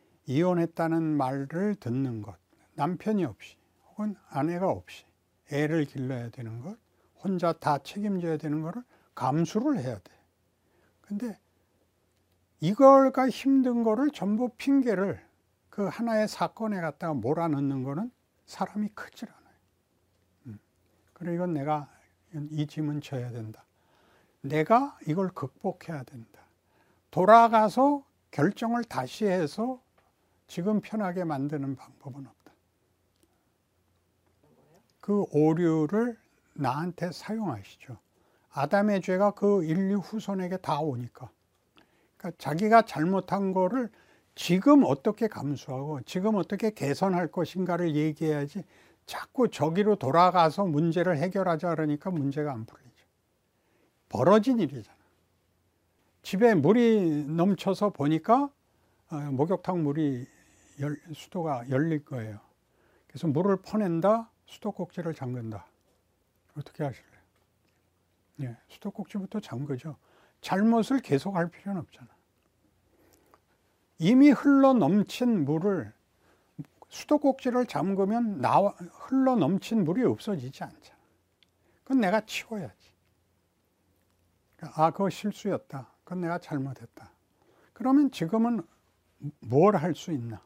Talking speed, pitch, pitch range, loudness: 240 characters per minute, 160 Hz, 125-205 Hz, -27 LUFS